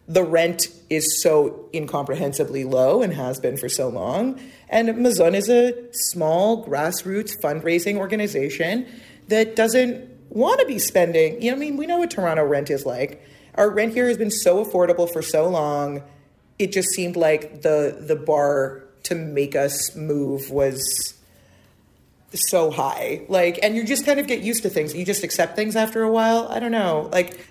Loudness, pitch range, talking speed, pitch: -21 LUFS, 150-225 Hz, 180 wpm, 180 Hz